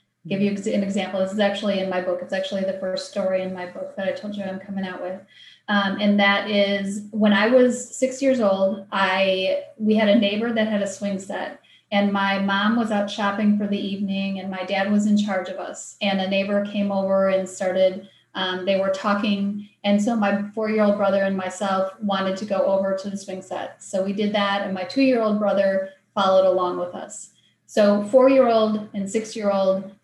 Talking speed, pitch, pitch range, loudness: 210 wpm, 200 Hz, 190-210 Hz, -22 LUFS